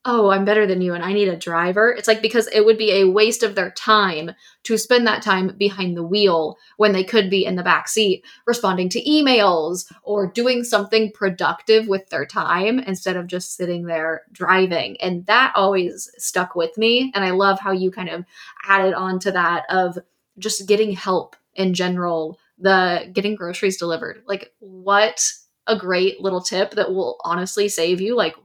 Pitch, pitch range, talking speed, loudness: 195 Hz, 180-215 Hz, 190 wpm, -19 LUFS